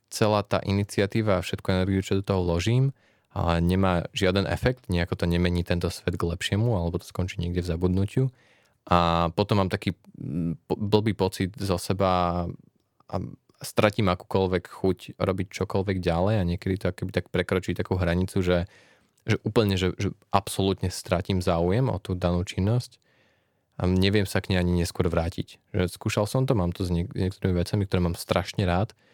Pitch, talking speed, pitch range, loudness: 95 Hz, 175 wpm, 90-105 Hz, -26 LUFS